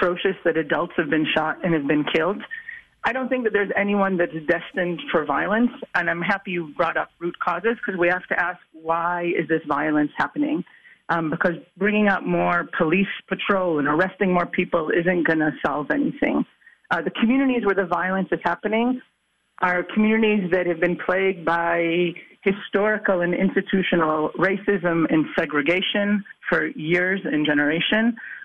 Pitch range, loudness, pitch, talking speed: 170-200 Hz, -22 LUFS, 180 Hz, 165 wpm